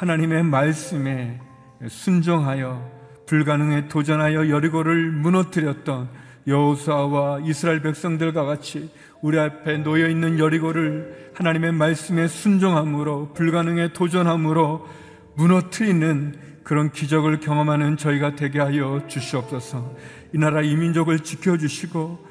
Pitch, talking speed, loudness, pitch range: 155 Hz, 305 characters per minute, -21 LUFS, 145-165 Hz